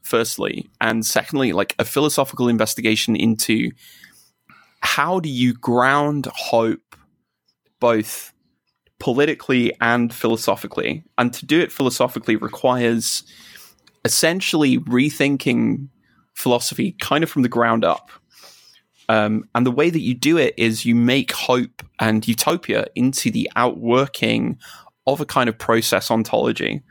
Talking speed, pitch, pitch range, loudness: 125 wpm, 125 Hz, 115-140 Hz, -19 LUFS